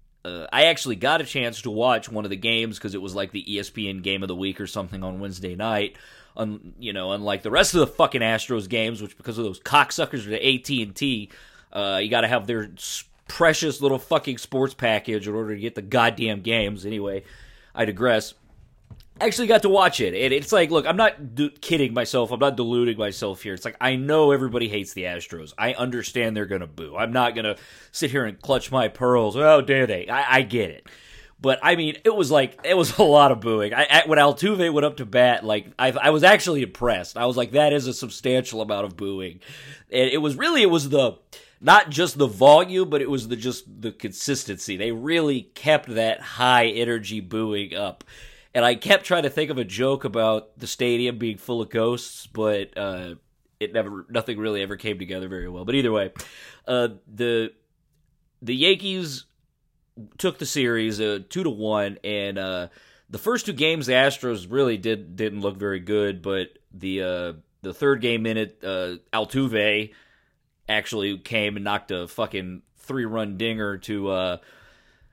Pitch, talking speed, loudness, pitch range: 115 Hz, 200 wpm, -22 LUFS, 105-135 Hz